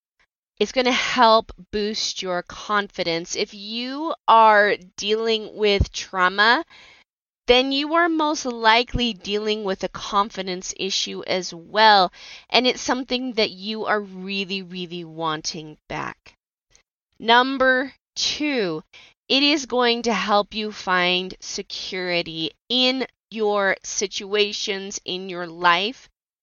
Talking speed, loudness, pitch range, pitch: 115 wpm, -21 LUFS, 185-240 Hz, 210 Hz